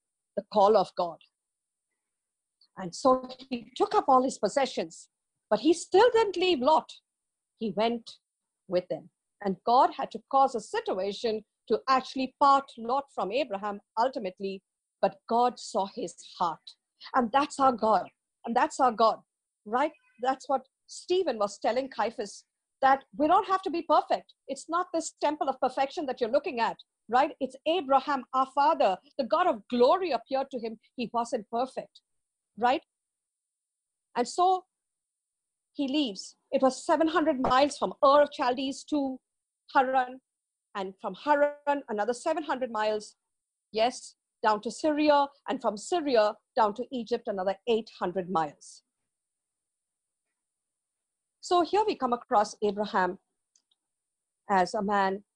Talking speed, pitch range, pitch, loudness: 140 wpm, 215-290 Hz, 255 Hz, -28 LUFS